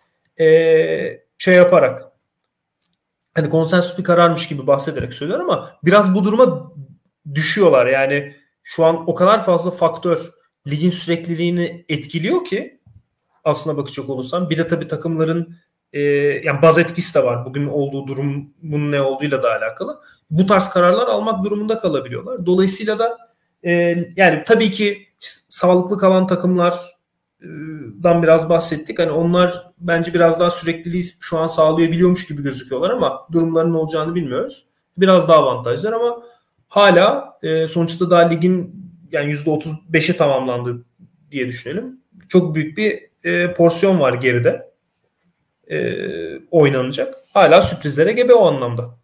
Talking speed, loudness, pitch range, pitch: 135 wpm, -16 LUFS, 155-185 Hz, 170 Hz